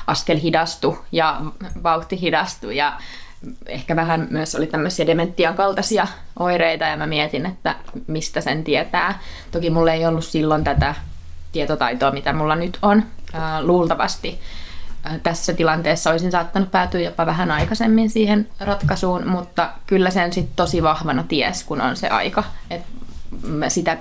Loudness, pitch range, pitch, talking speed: -20 LUFS, 155-180 Hz, 165 Hz, 145 wpm